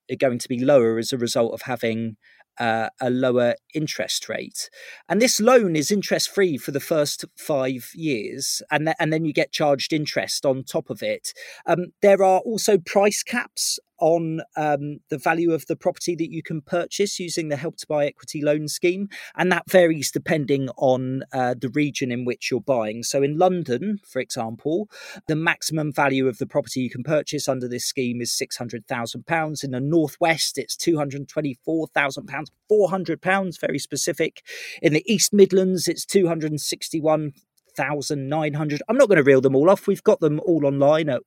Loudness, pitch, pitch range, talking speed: -22 LUFS, 155 Hz, 135-175 Hz, 175 wpm